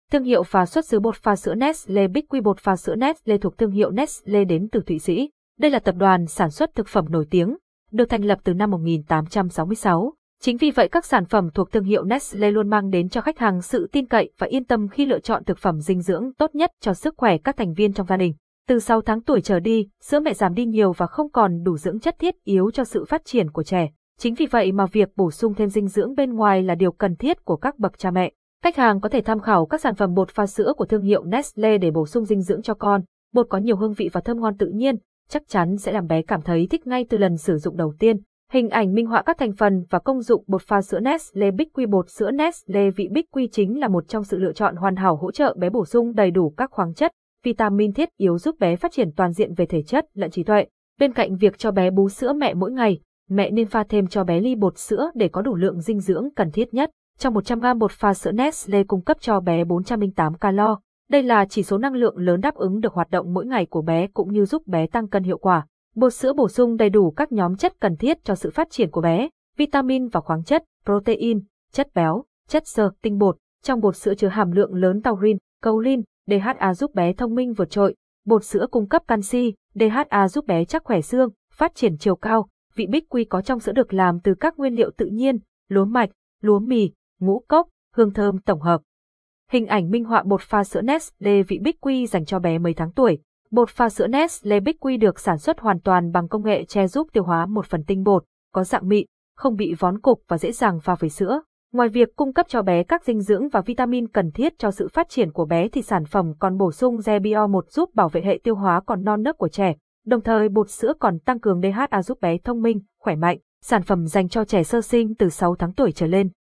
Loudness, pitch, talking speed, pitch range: -21 LUFS, 210 Hz, 255 wpm, 190-245 Hz